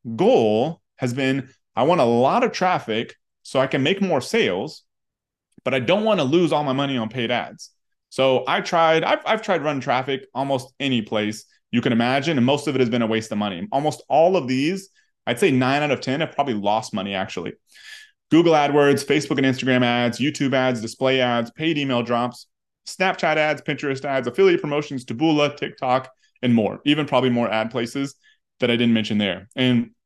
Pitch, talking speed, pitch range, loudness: 130 Hz, 200 wpm, 120-150 Hz, -21 LUFS